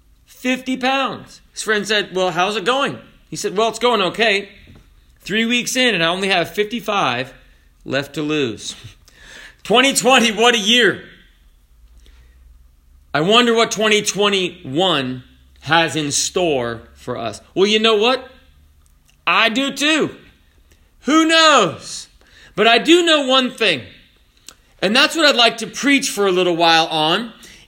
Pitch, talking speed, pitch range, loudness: 205 Hz, 145 wpm, 150-245 Hz, -16 LUFS